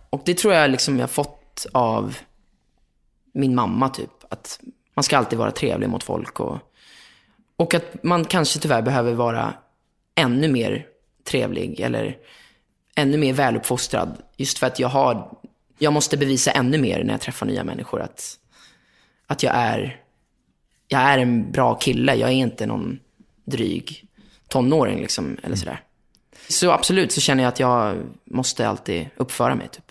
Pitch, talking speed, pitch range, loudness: 135 Hz, 160 wpm, 125-150 Hz, -21 LUFS